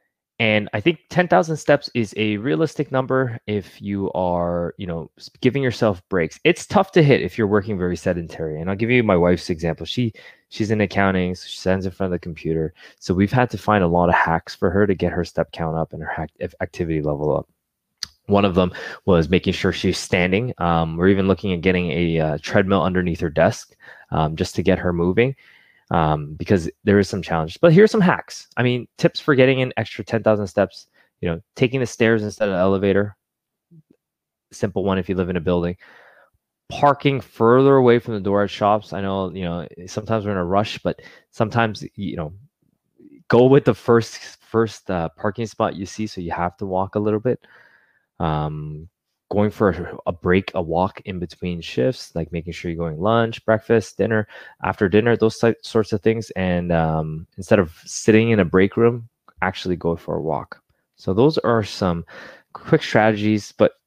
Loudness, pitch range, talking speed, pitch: -20 LUFS, 90-115 Hz, 200 wpm, 100 Hz